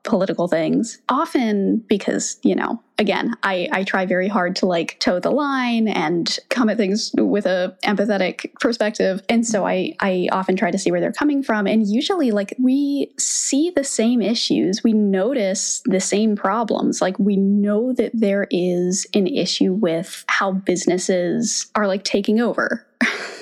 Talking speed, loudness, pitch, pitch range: 165 wpm, -19 LUFS, 210 Hz, 190-245 Hz